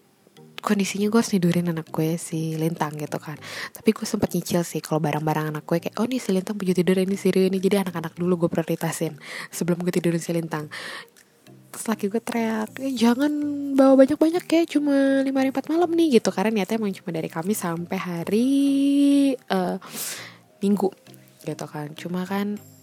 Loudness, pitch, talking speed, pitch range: -23 LUFS, 190 Hz, 180 wpm, 170-230 Hz